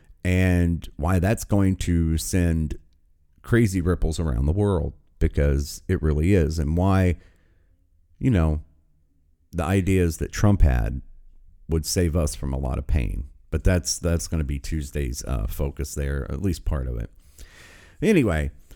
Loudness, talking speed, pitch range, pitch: -24 LUFS, 155 wpm, 75-90 Hz, 80 Hz